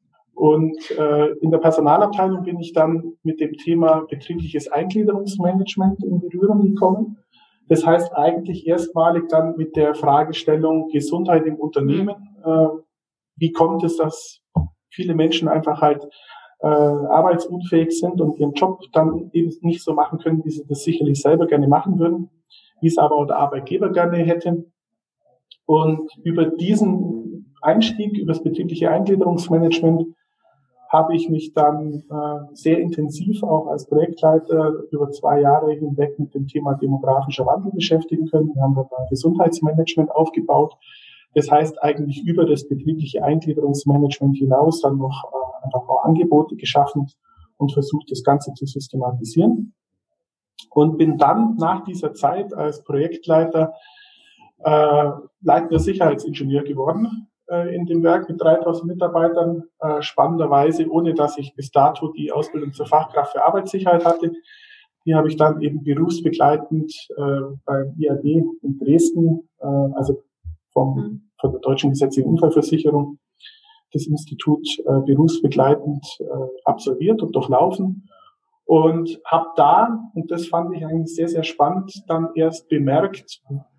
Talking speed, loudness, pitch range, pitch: 135 wpm, -19 LUFS, 145-170 Hz, 160 Hz